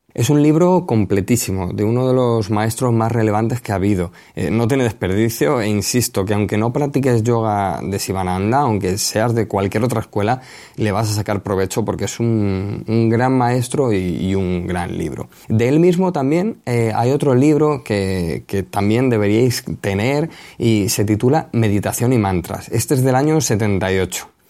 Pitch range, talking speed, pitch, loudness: 100-125 Hz, 180 wpm, 110 Hz, -17 LUFS